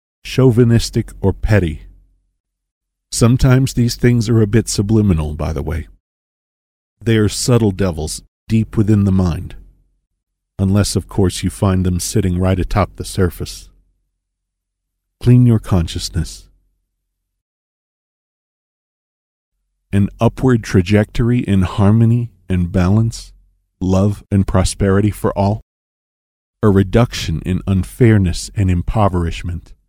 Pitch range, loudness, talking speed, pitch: 90-105 Hz, -16 LUFS, 105 wpm, 95 Hz